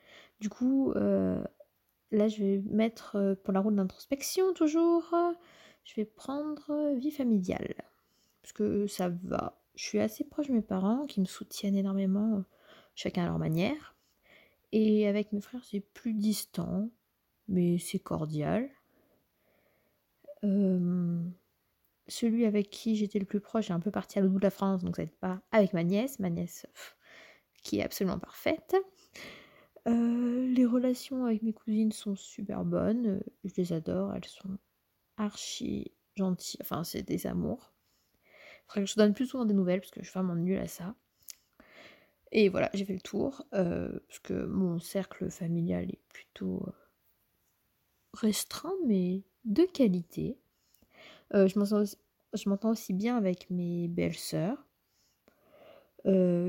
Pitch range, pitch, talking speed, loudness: 190-235 Hz, 205 Hz, 155 wpm, -32 LUFS